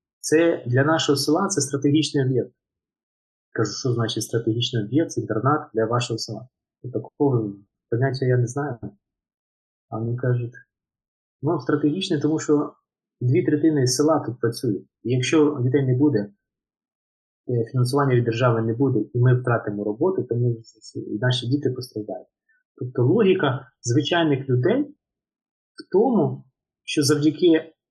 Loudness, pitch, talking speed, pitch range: -22 LUFS, 125 Hz, 130 wpm, 115-150 Hz